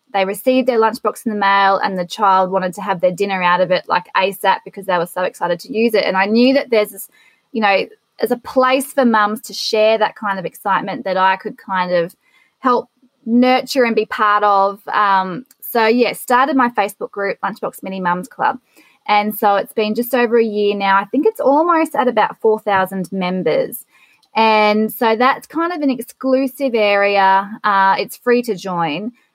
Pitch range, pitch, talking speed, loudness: 195-245 Hz, 215 Hz, 200 wpm, -16 LUFS